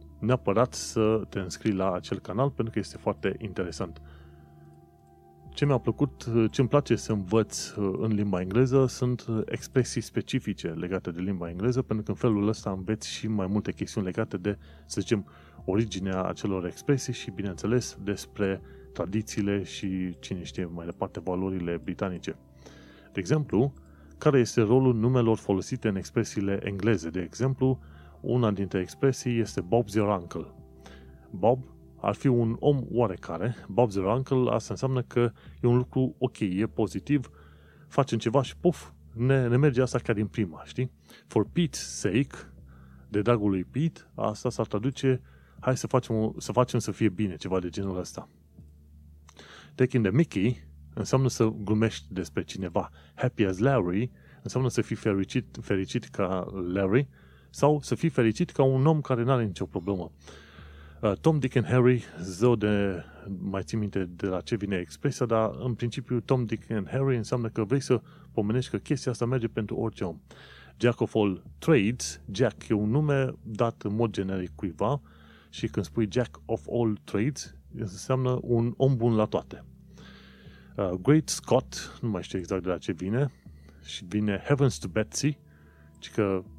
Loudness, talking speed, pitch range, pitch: -28 LUFS, 165 wpm, 90-125 Hz, 105 Hz